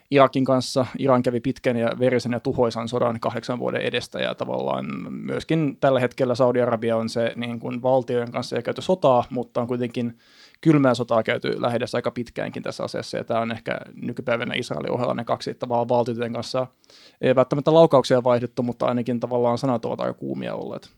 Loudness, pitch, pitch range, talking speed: -23 LUFS, 125 Hz, 120-130 Hz, 180 wpm